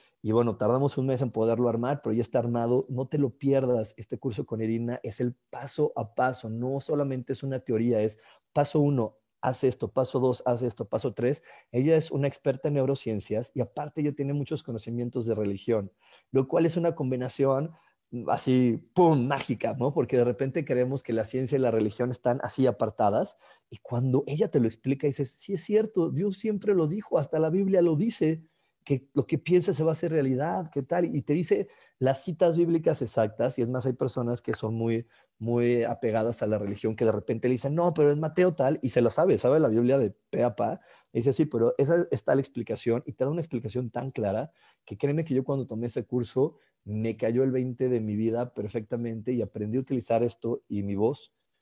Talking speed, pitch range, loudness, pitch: 215 wpm, 115-145 Hz, -28 LUFS, 130 Hz